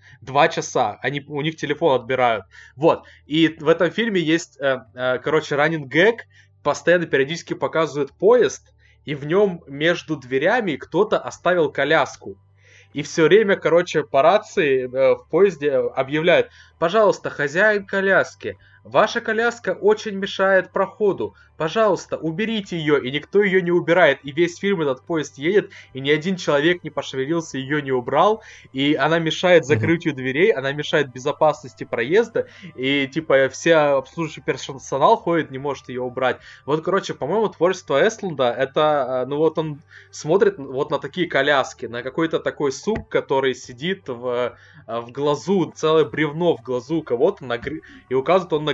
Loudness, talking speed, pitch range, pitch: -20 LUFS, 145 wpm, 135-195 Hz, 155 Hz